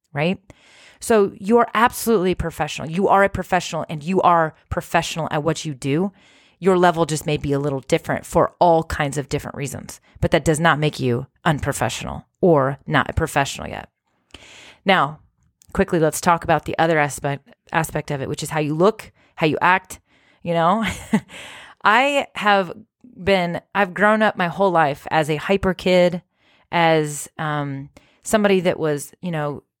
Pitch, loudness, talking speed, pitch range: 165 Hz, -20 LUFS, 170 wpm, 150-190 Hz